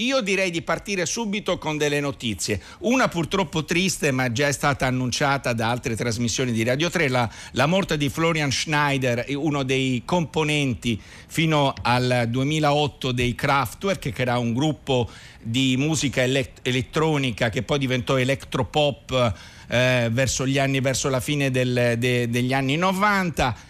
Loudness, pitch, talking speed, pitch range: -22 LUFS, 135 Hz, 150 wpm, 125-150 Hz